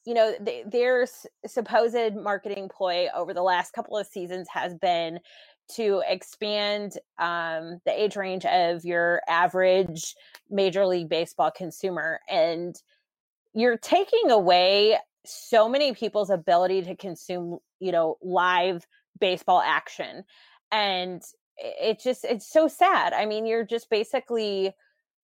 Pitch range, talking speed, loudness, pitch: 180-225 Hz, 130 wpm, -25 LUFS, 195 Hz